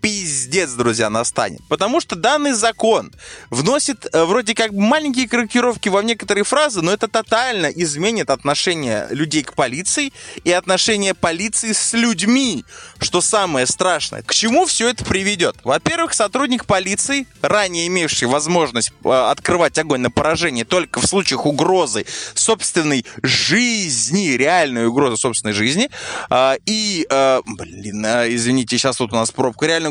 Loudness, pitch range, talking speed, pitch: -17 LUFS, 135-225 Hz, 140 wpm, 180 Hz